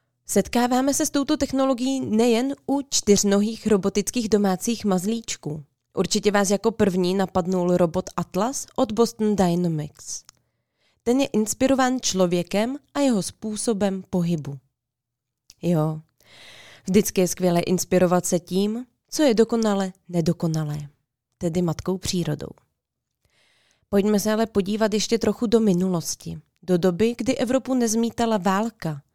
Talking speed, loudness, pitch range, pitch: 115 wpm, -23 LUFS, 175-230 Hz, 200 Hz